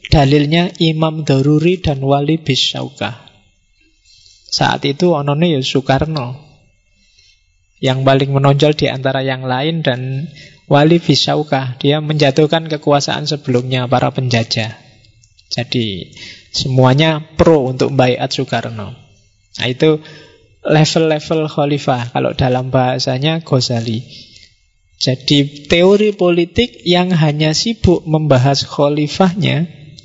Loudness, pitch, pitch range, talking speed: -14 LUFS, 140 Hz, 125-155 Hz, 100 wpm